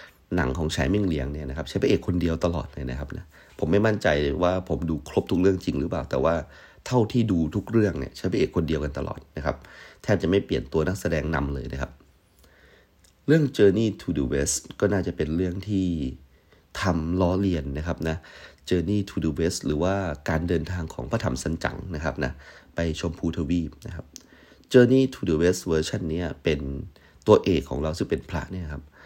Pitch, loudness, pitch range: 80 Hz, -25 LUFS, 75-90 Hz